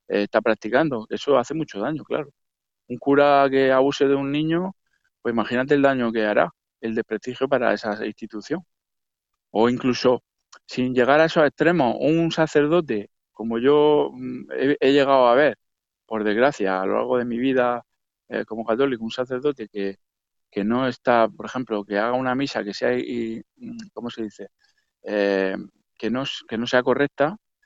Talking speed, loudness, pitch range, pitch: 165 wpm, -22 LUFS, 110-140 Hz, 125 Hz